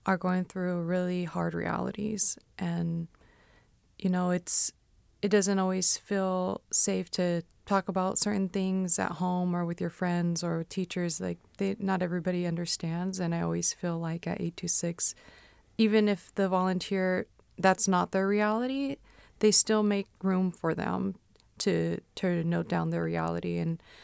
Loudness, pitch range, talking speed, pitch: -29 LUFS, 170-195 Hz, 150 wpm, 180 Hz